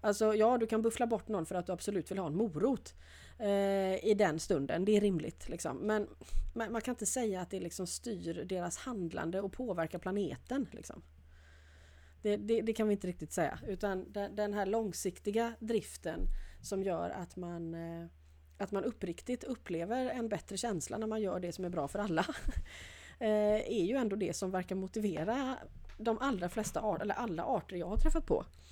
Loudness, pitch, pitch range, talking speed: -36 LUFS, 200 Hz, 175-220 Hz, 190 wpm